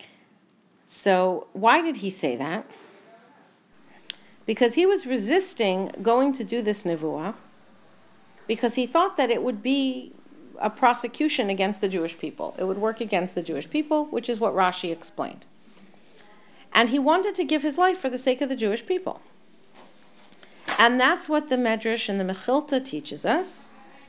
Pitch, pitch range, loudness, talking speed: 240 Hz, 200-300 Hz, -24 LUFS, 160 wpm